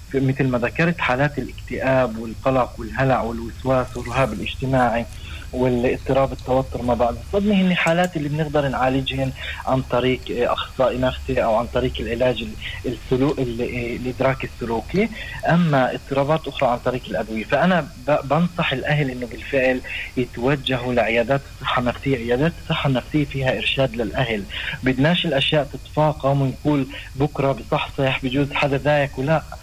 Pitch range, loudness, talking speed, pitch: 120-140 Hz, -21 LUFS, 130 wpm, 130 Hz